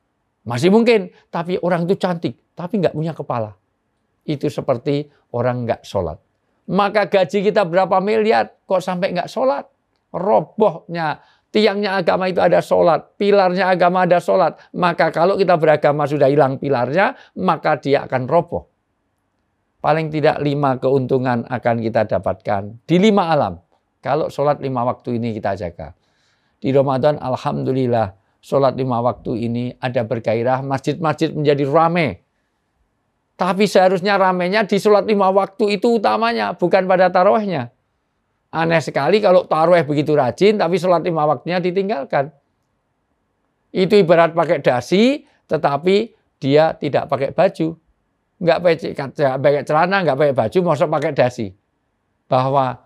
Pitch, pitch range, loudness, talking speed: 150 Hz, 125-185 Hz, -17 LUFS, 130 wpm